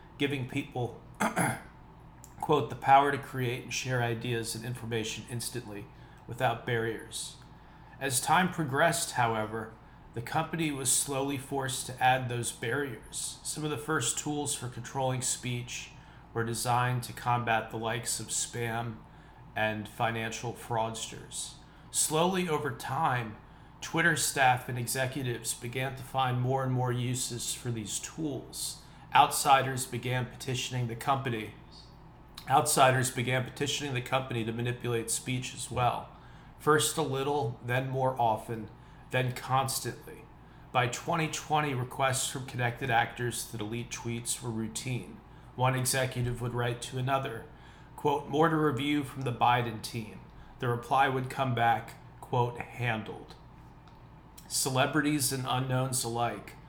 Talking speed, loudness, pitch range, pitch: 130 wpm, -31 LUFS, 120-135 Hz, 125 Hz